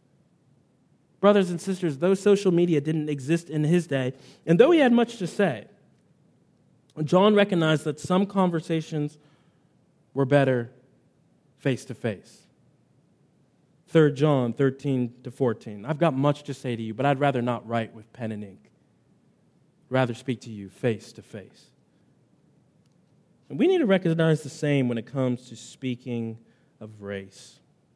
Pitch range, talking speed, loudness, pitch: 125-170 Hz, 150 wpm, -25 LUFS, 145 Hz